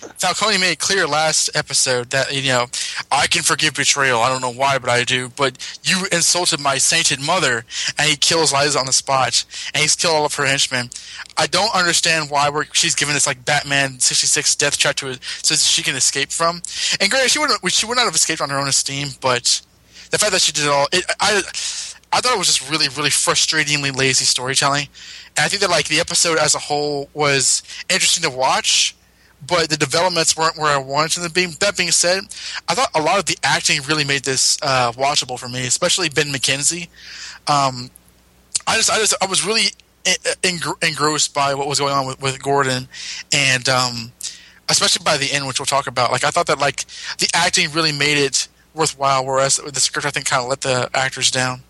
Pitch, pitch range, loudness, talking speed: 145 Hz, 135-165 Hz, -16 LUFS, 215 wpm